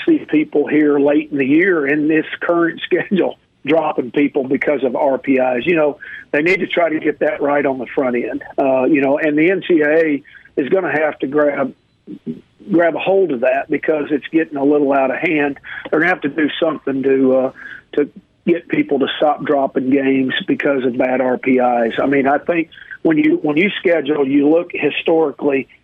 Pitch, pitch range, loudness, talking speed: 145 Hz, 135-170 Hz, -16 LUFS, 200 wpm